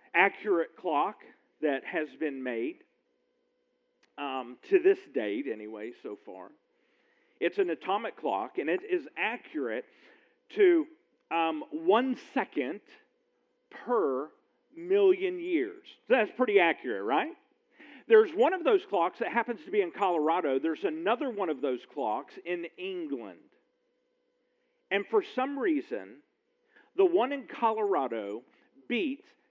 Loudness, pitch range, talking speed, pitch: -30 LUFS, 285-425 Hz, 125 wpm, 375 Hz